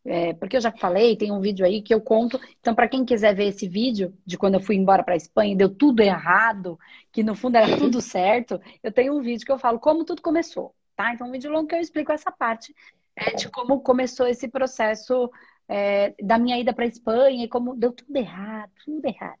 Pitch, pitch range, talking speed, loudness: 235 Hz, 205-260 Hz, 230 wpm, -22 LUFS